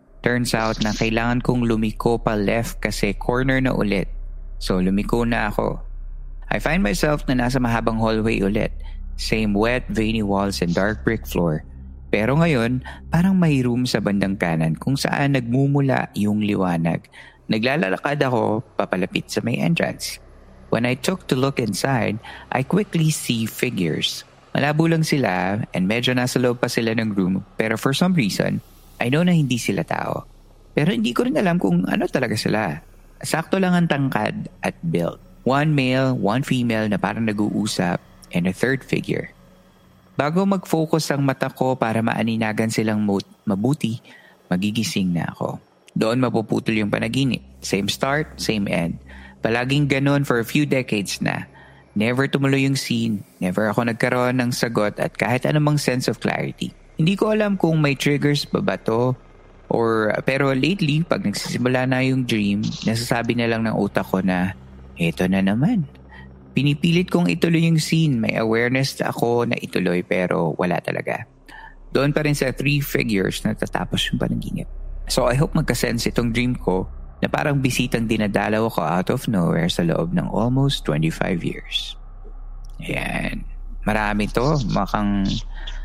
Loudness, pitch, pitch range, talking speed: -21 LUFS, 120 Hz, 105-145 Hz, 160 wpm